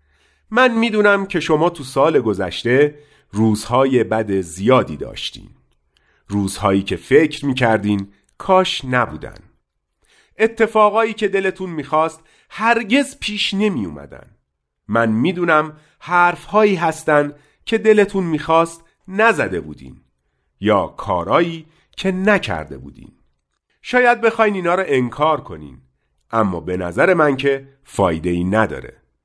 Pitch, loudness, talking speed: 145 Hz, -17 LUFS, 110 wpm